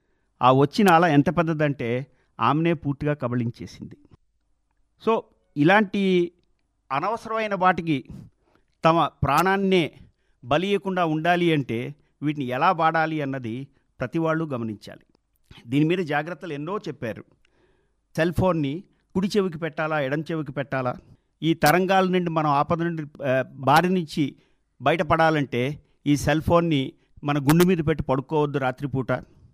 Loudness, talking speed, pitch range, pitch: -23 LUFS, 110 wpm, 140-175 Hz, 155 Hz